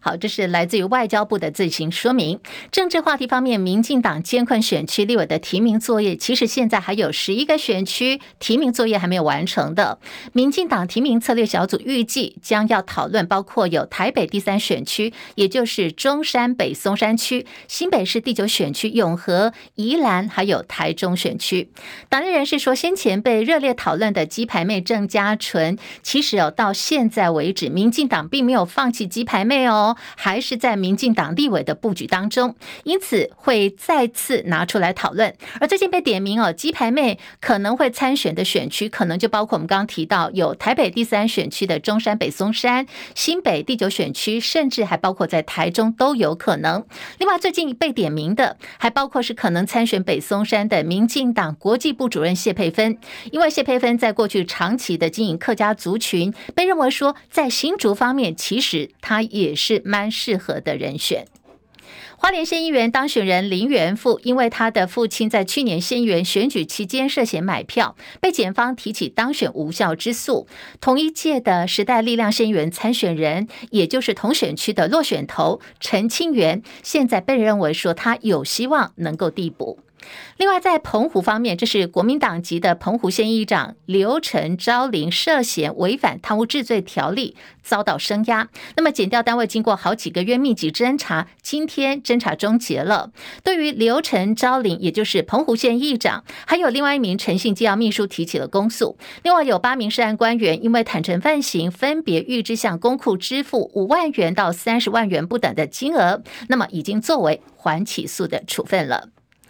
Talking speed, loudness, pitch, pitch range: 285 characters per minute, -19 LUFS, 225 Hz, 195-255 Hz